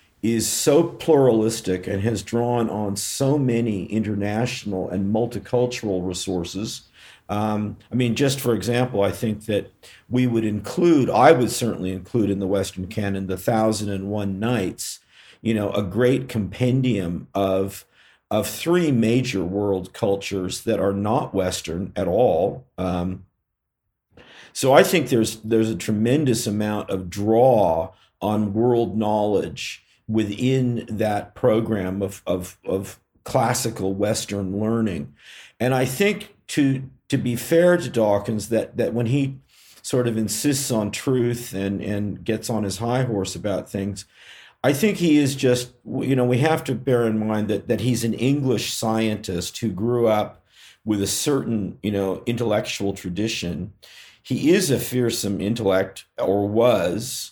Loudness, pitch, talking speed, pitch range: -22 LUFS, 110 Hz, 145 wpm, 100-125 Hz